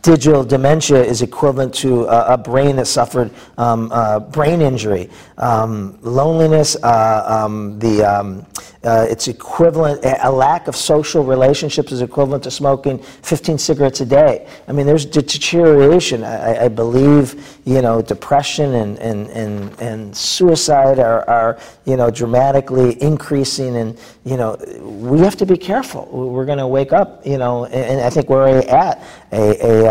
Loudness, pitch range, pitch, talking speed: -14 LUFS, 115-145 Hz, 130 Hz, 160 wpm